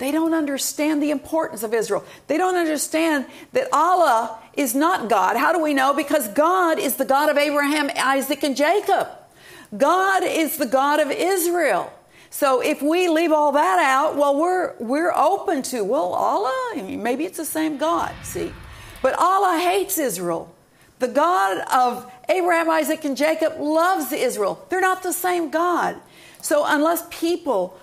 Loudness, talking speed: -20 LUFS, 170 wpm